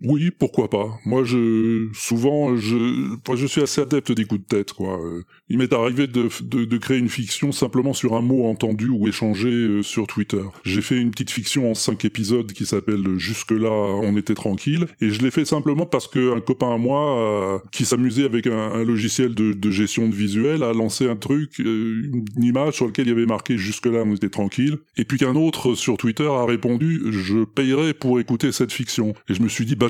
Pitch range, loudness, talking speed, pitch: 110-130 Hz, -21 LUFS, 225 wpm, 120 Hz